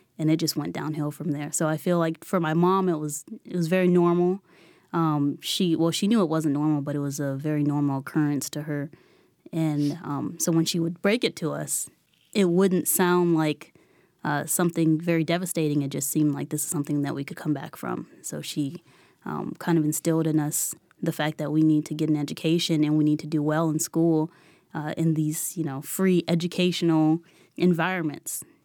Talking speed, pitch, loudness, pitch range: 210 wpm, 160 Hz, -25 LUFS, 150-170 Hz